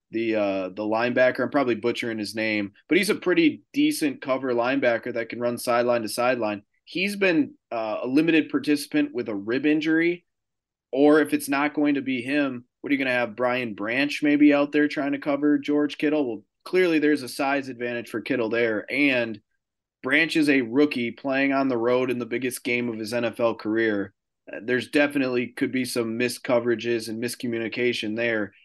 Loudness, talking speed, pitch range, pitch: -24 LUFS, 195 wpm, 115-145 Hz, 125 Hz